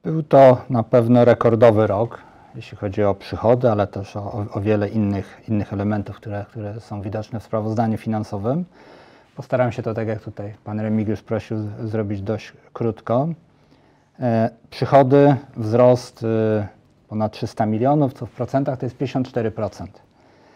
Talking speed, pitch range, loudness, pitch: 150 wpm, 105-125 Hz, -20 LUFS, 115 Hz